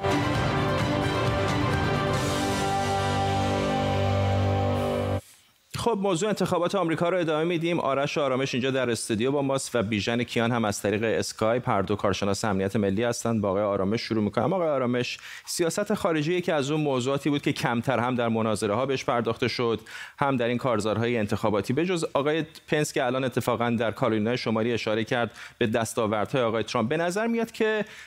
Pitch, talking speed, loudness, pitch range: 120 Hz, 160 wpm, -26 LUFS, 110-150 Hz